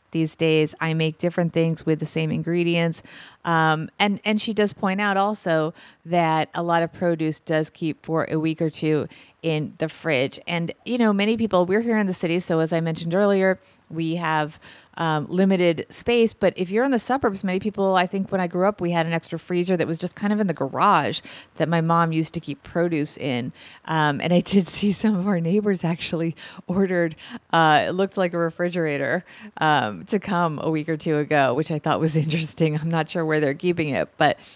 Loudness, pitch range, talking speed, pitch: -23 LUFS, 160-190 Hz, 220 wpm, 170 Hz